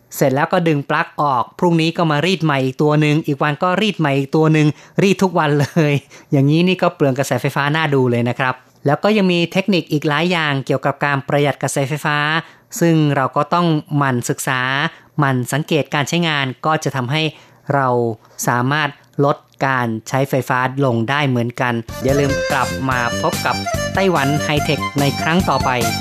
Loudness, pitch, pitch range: -17 LUFS, 145 Hz, 135-160 Hz